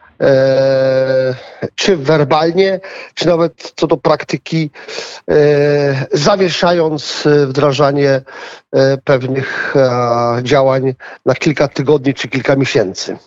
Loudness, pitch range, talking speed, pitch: -13 LUFS, 135-165 Hz, 75 wpm, 145 Hz